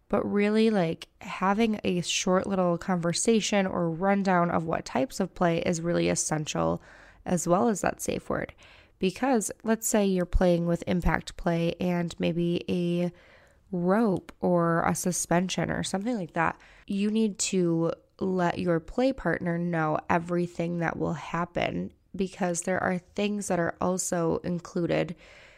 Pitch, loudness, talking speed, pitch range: 175 Hz, -27 LUFS, 150 wpm, 170-195 Hz